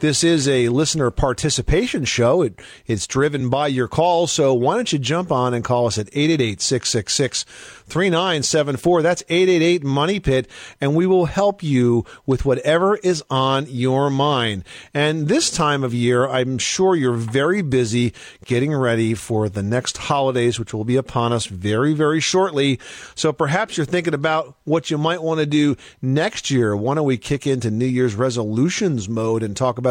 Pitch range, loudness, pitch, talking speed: 125-160 Hz, -19 LUFS, 140 Hz, 180 wpm